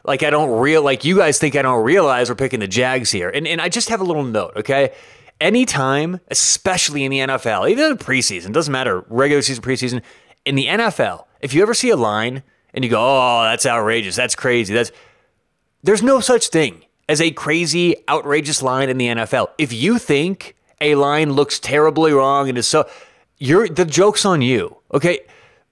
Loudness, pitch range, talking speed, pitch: -16 LUFS, 125-180 Hz, 200 wpm, 145 Hz